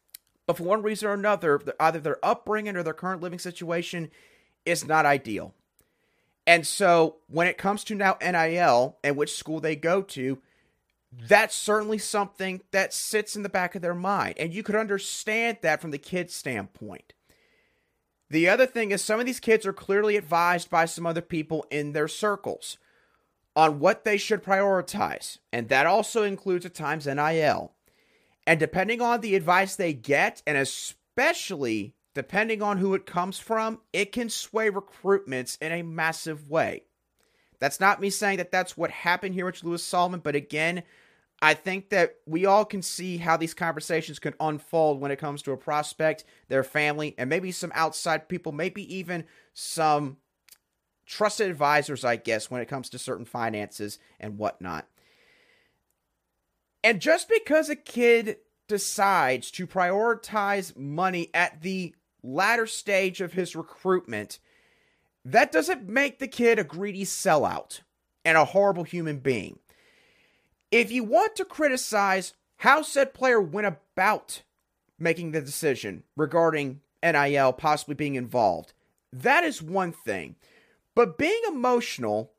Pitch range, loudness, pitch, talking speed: 155-205 Hz, -26 LUFS, 180 Hz, 155 wpm